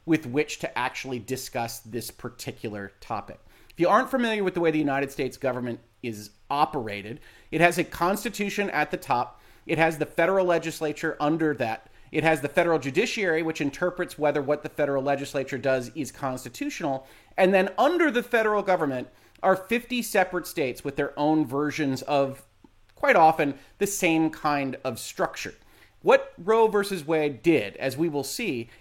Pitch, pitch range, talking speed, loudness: 150 Hz, 135-180 Hz, 170 wpm, -26 LUFS